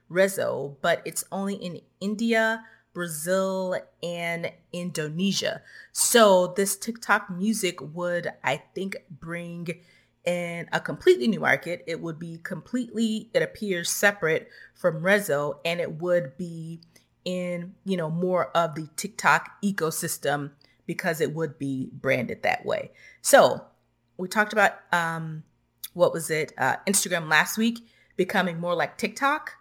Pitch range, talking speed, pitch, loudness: 165-200 Hz, 135 wpm, 175 Hz, -25 LUFS